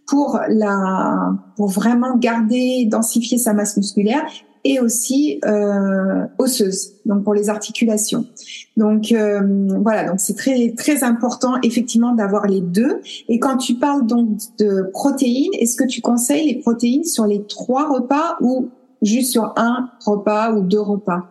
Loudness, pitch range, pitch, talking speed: -17 LUFS, 210-255 Hz, 230 Hz, 155 wpm